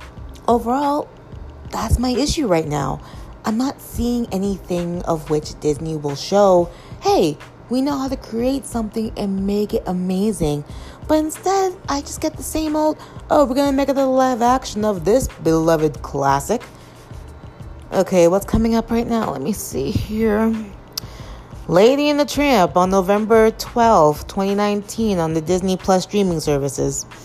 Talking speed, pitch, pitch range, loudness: 155 wpm, 210 Hz, 175-255 Hz, -19 LUFS